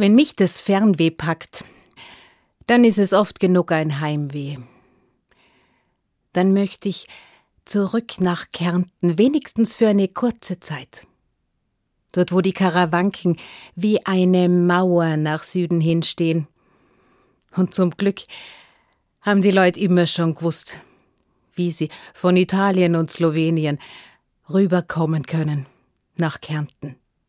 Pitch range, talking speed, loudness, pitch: 160-195 Hz, 115 wpm, -19 LUFS, 180 Hz